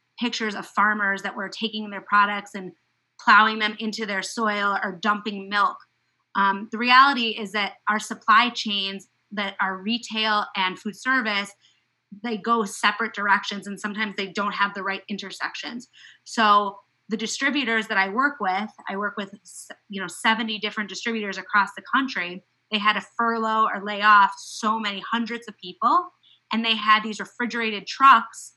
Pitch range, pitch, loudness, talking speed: 200-225 Hz, 210 Hz, -23 LUFS, 165 wpm